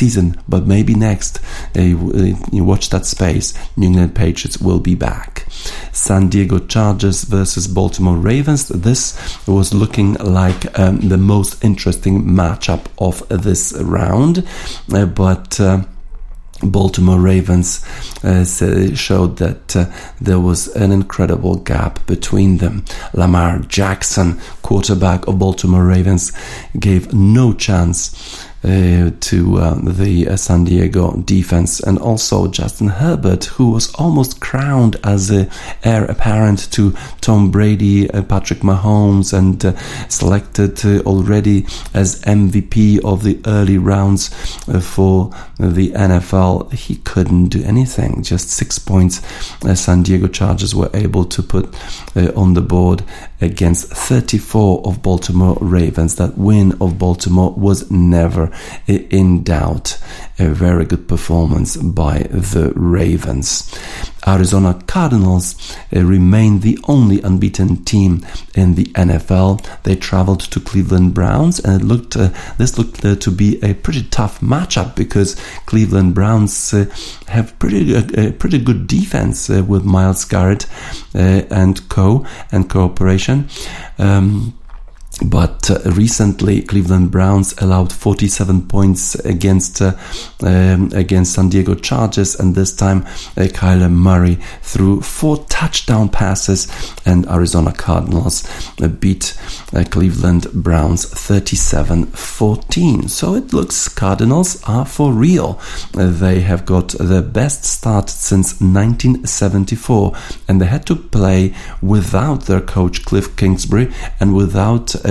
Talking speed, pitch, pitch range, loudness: 130 wpm, 95 Hz, 90-105 Hz, -14 LUFS